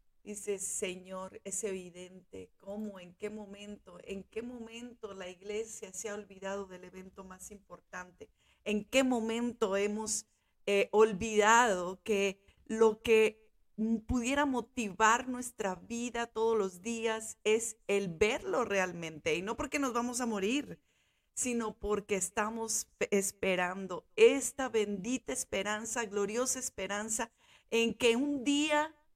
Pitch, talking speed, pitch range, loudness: 215 Hz, 125 wpm, 195-235 Hz, -33 LUFS